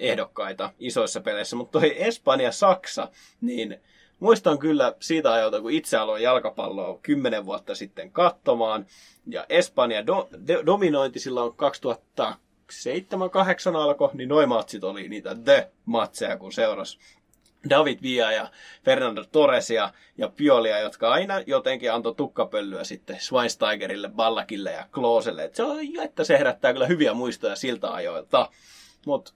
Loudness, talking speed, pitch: -24 LUFS, 140 wpm, 260 Hz